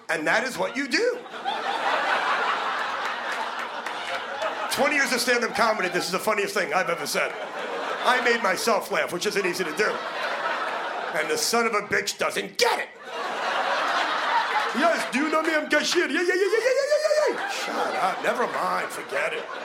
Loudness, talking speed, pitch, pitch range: -24 LUFS, 175 wpm, 300 Hz, 235-385 Hz